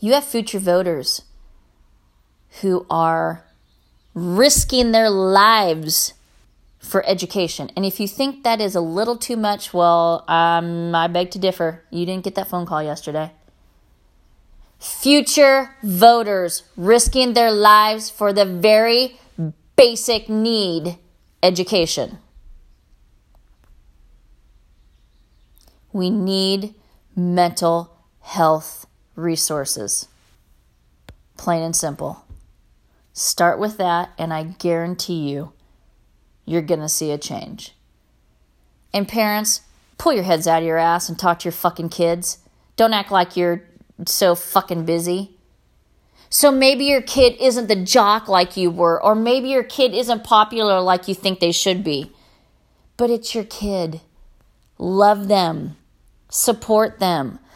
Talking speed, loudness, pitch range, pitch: 125 wpm, -18 LUFS, 160-210 Hz, 180 Hz